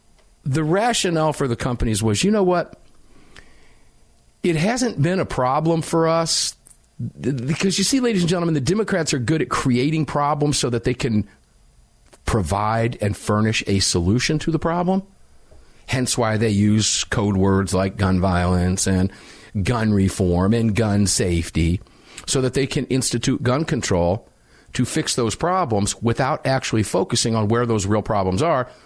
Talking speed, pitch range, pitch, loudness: 160 wpm, 100-155 Hz, 120 Hz, -20 LUFS